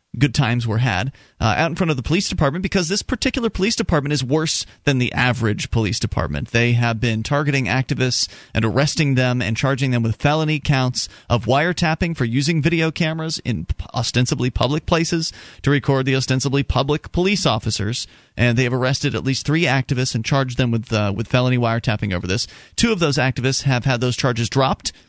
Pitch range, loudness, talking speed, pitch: 120-155 Hz, -19 LUFS, 195 wpm, 130 Hz